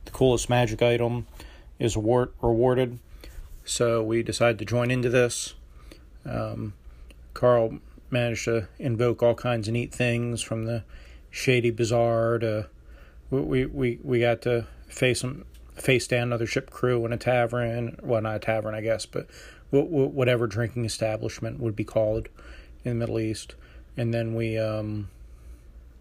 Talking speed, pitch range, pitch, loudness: 145 wpm, 105-120 Hz, 115 Hz, -26 LUFS